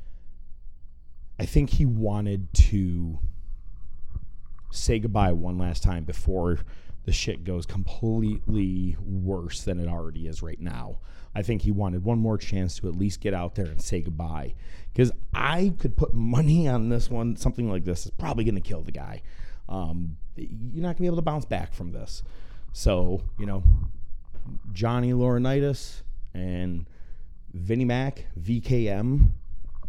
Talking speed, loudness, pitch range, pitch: 150 wpm, -27 LUFS, 85-115 Hz, 95 Hz